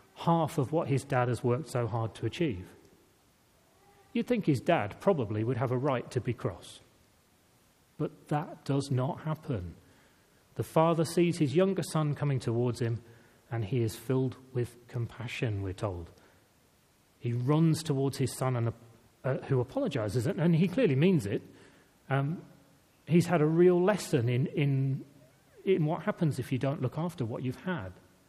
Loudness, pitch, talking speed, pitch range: -31 LUFS, 130 Hz, 170 wpm, 120-155 Hz